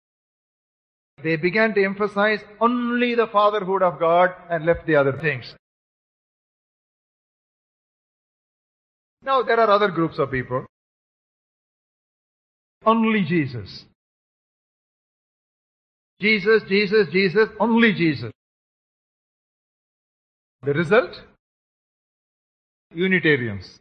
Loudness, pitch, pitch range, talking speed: -20 LUFS, 185 Hz, 155-215 Hz, 80 wpm